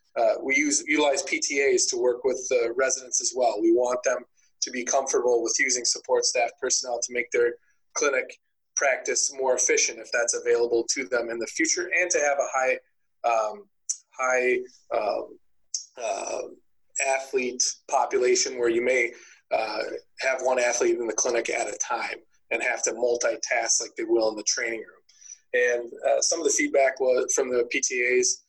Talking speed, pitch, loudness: 175 wpm, 380 Hz, -25 LUFS